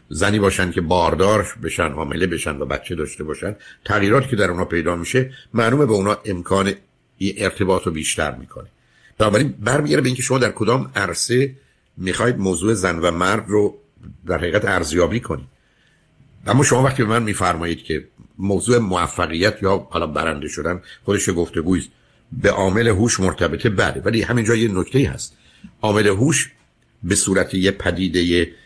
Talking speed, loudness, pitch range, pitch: 160 wpm, -19 LUFS, 90-115 Hz, 100 Hz